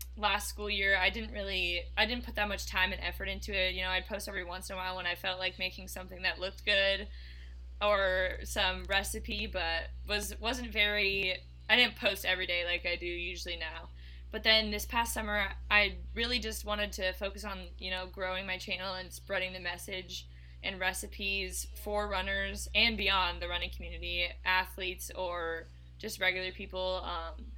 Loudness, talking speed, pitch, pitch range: -32 LUFS, 190 wpm, 185 Hz, 175-205 Hz